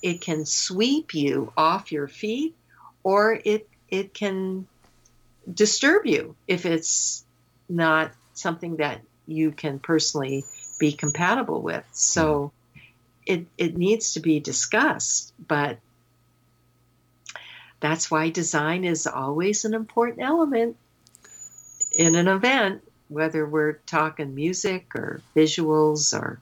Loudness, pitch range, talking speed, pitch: -23 LUFS, 145-190 Hz, 115 wpm, 160 Hz